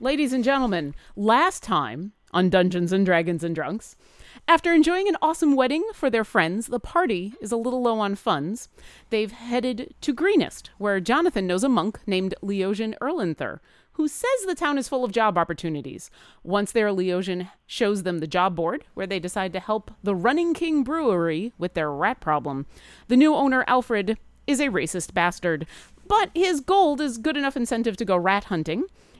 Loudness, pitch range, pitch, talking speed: -24 LUFS, 185-280 Hz, 220 Hz, 180 wpm